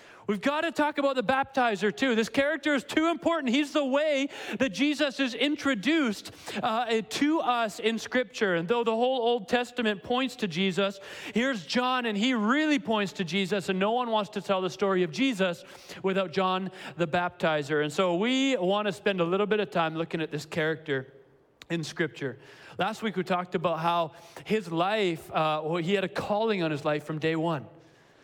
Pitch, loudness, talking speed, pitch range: 205 Hz, -28 LUFS, 200 wpm, 175-250 Hz